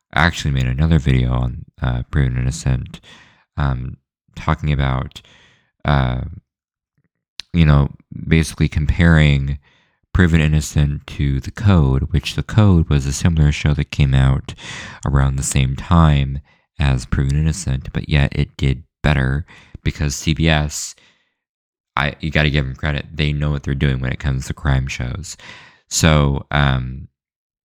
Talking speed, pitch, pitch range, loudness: 140 wpm, 70 Hz, 65-75 Hz, -18 LUFS